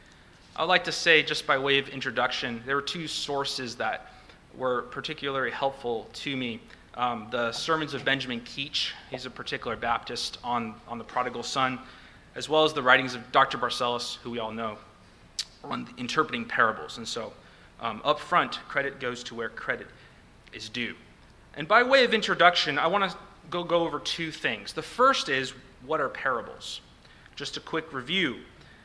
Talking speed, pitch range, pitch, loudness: 175 wpm, 120-155 Hz, 135 Hz, -27 LUFS